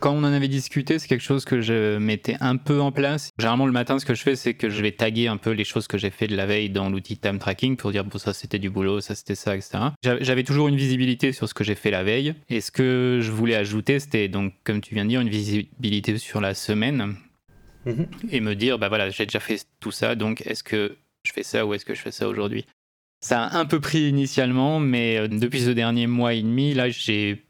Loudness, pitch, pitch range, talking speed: -24 LUFS, 115 Hz, 105-130 Hz, 260 wpm